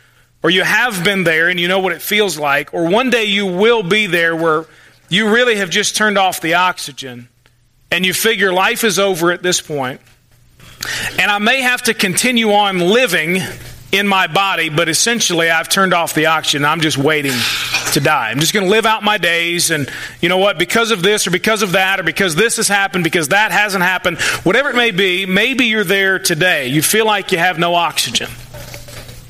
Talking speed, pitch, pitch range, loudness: 210 wpm, 185 Hz, 160-210 Hz, -13 LUFS